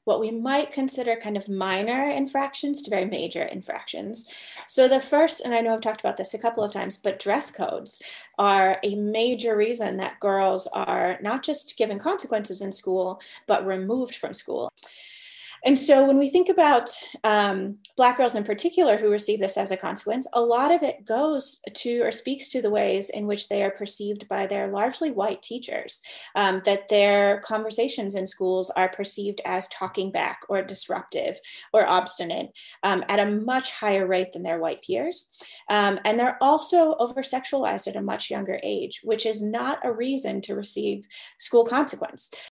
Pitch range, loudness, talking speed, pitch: 200-265 Hz, -24 LUFS, 180 wpm, 215 Hz